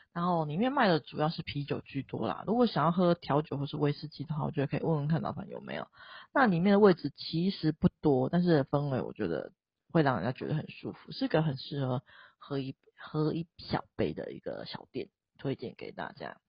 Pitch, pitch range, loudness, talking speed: 155 Hz, 145-175 Hz, -31 LUFS, 320 characters per minute